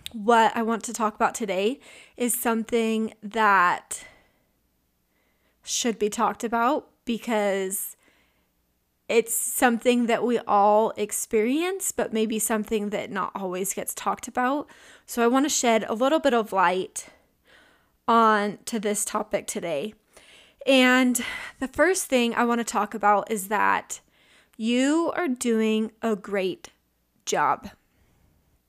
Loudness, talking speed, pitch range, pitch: -24 LUFS, 130 wpm, 205-245 Hz, 225 Hz